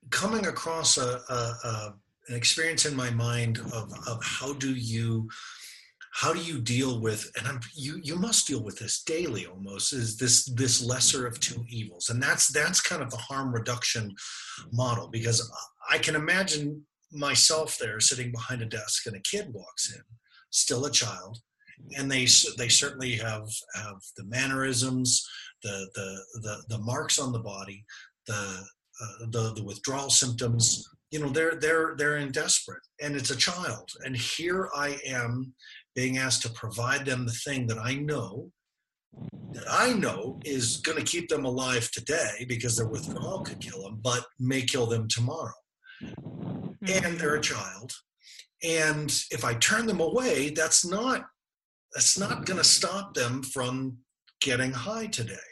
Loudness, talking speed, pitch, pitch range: -27 LUFS, 165 wpm, 125 Hz, 115-150 Hz